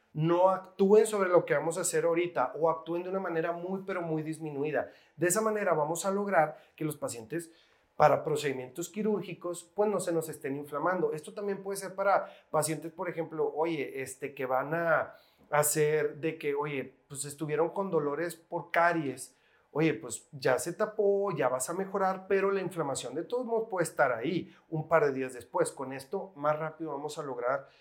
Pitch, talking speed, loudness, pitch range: 165 Hz, 190 wpm, -31 LUFS, 150-190 Hz